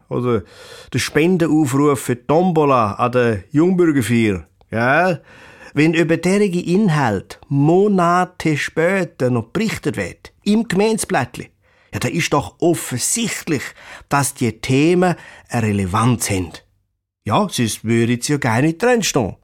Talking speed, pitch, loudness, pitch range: 120 wpm, 145 Hz, -17 LUFS, 115-175 Hz